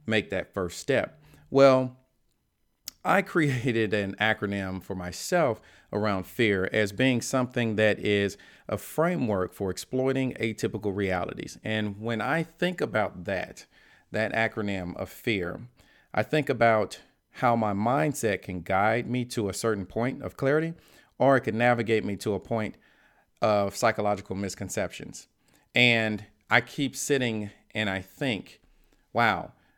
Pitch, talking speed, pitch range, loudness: 110 Hz, 135 wpm, 100-125 Hz, -27 LUFS